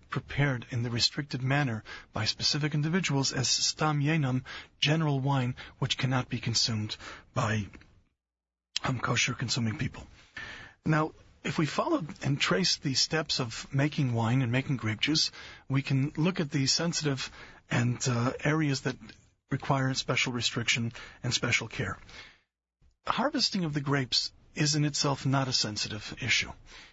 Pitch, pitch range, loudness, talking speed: 135 Hz, 120-150 Hz, -29 LUFS, 145 wpm